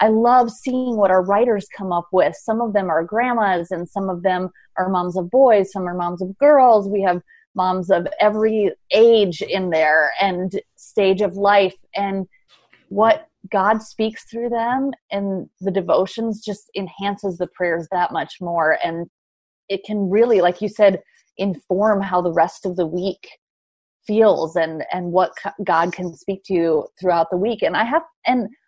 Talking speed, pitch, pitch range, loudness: 180 wpm, 195 Hz, 180-220 Hz, -19 LUFS